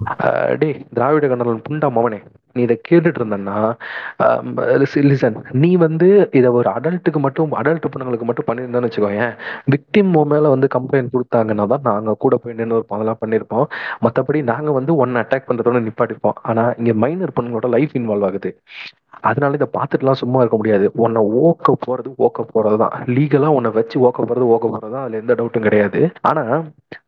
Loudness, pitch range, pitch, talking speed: -17 LUFS, 115-145 Hz, 125 Hz, 155 wpm